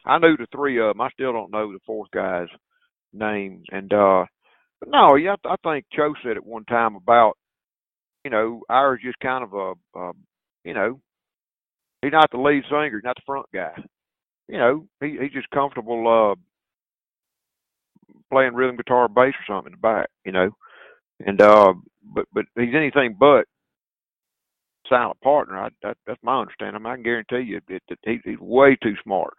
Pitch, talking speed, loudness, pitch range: 125 Hz, 185 wpm, -20 LUFS, 110-140 Hz